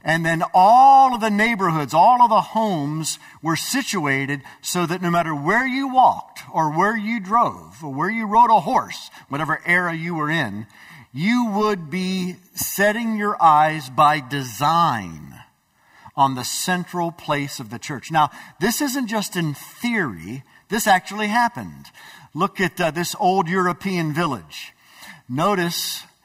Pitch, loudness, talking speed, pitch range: 175 Hz, -19 LUFS, 150 wpm, 150-210 Hz